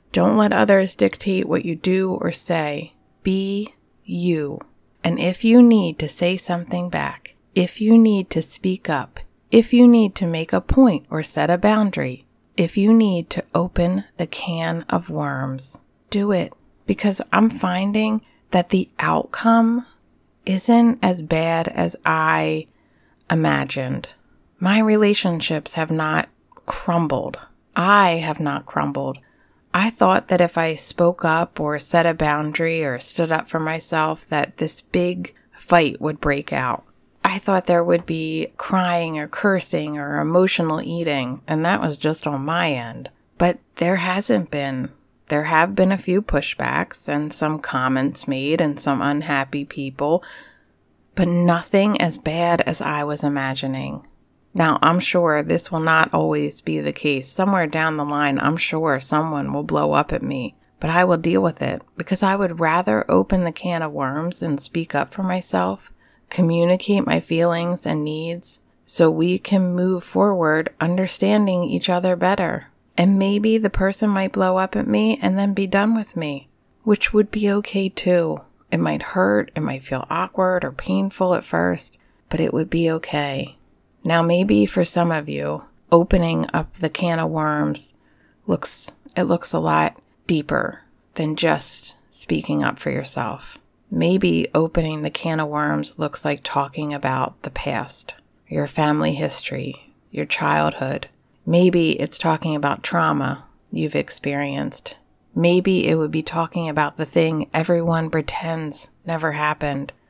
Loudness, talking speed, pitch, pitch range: -20 LUFS, 155 wpm, 165 Hz, 150-185 Hz